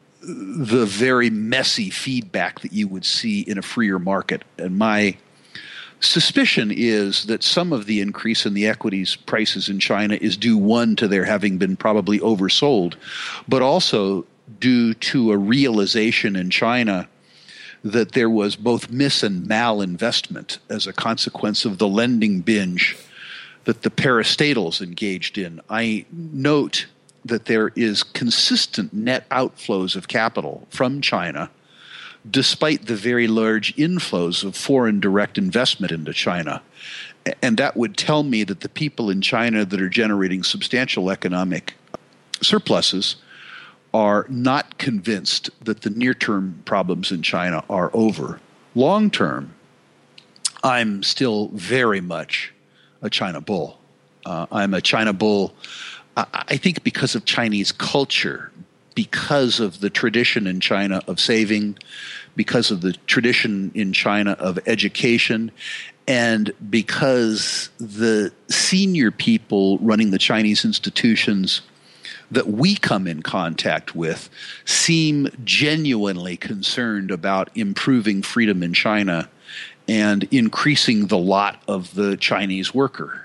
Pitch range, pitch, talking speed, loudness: 100-135 Hz, 110 Hz, 130 wpm, -19 LUFS